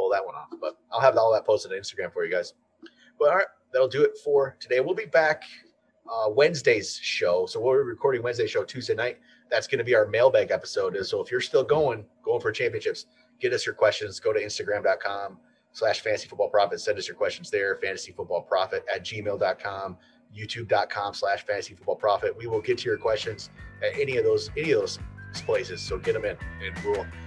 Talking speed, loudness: 215 wpm, -26 LUFS